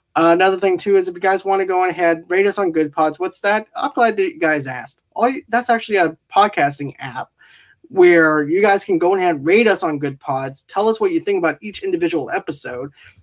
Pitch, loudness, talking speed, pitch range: 190 Hz, -17 LUFS, 240 wpm, 155-235 Hz